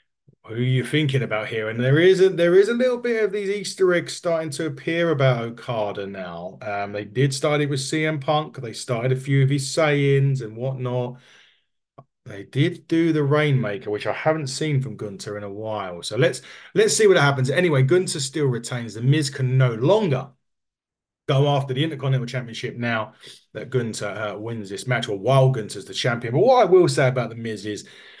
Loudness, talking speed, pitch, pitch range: -22 LUFS, 205 wpm, 130 Hz, 115-155 Hz